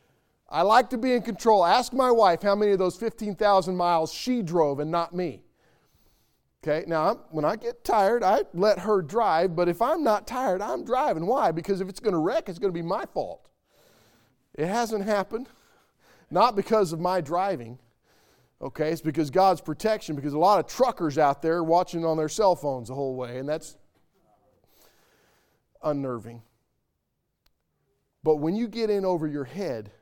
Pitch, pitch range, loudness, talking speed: 175 Hz, 155-215 Hz, -25 LUFS, 180 wpm